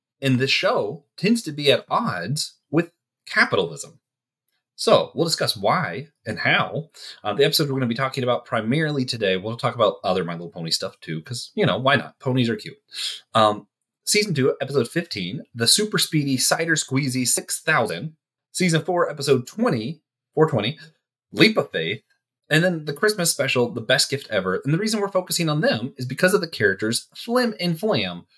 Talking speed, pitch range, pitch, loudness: 180 wpm, 120-170 Hz, 140 Hz, -21 LUFS